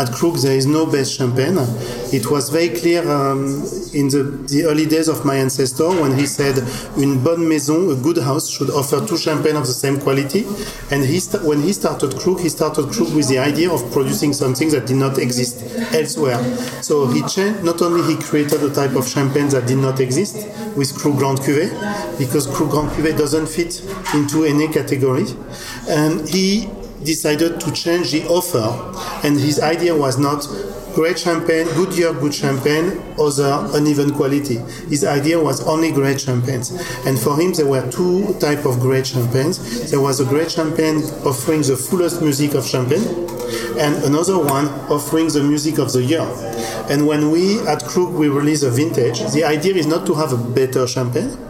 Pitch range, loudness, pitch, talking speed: 135-165 Hz, -17 LUFS, 150 Hz, 190 wpm